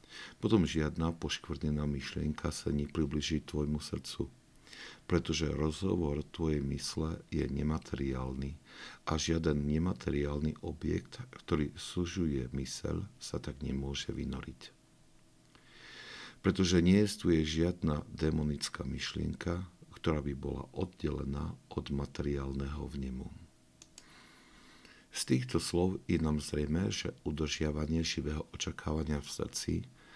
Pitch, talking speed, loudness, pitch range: 75 Hz, 100 wpm, -35 LUFS, 70-85 Hz